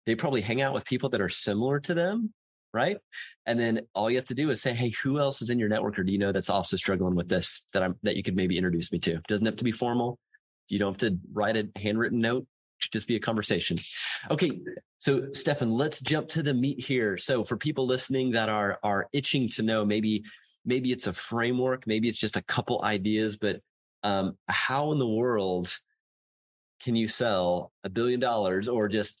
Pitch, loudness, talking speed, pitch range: 115 Hz, -28 LUFS, 225 wpm, 105-130 Hz